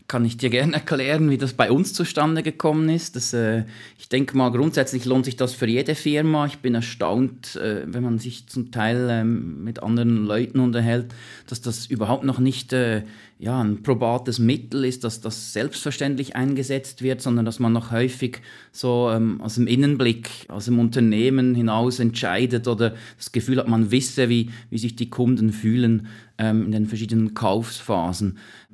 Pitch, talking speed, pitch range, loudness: 120 Hz, 180 wpm, 115-130 Hz, -22 LUFS